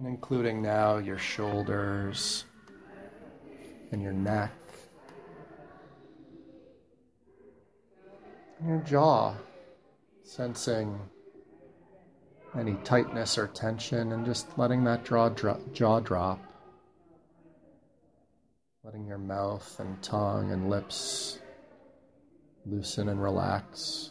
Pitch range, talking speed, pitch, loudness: 100-120 Hz, 80 wpm, 105 Hz, -30 LUFS